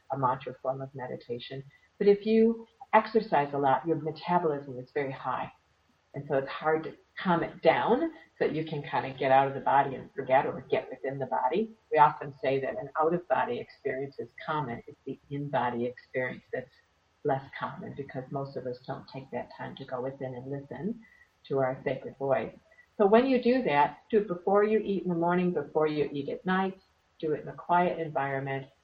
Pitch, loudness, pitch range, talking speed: 145 Hz, -29 LUFS, 135-175 Hz, 210 wpm